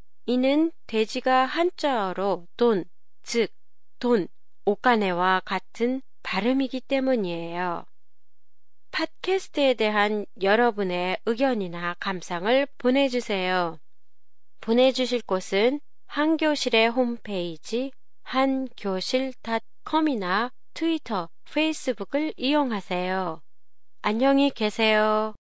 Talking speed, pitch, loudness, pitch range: 215 characters per minute, 235 Hz, -25 LUFS, 195-265 Hz